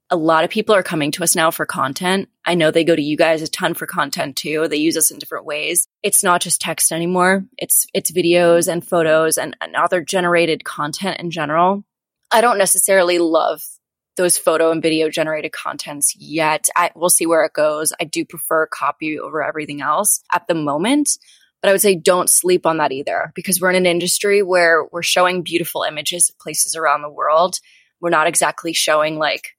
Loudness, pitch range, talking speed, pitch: -16 LUFS, 155-180 Hz, 205 wpm, 170 Hz